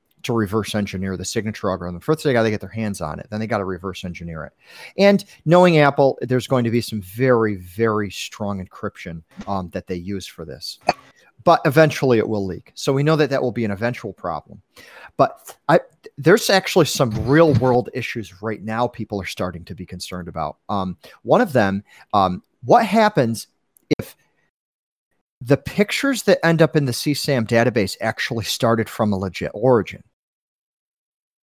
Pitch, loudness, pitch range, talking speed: 115 Hz, -20 LUFS, 95-140 Hz, 180 wpm